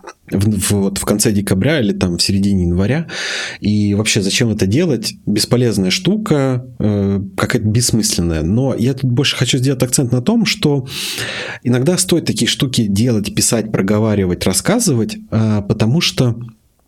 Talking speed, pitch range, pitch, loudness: 145 wpm, 100-135 Hz, 110 Hz, -15 LUFS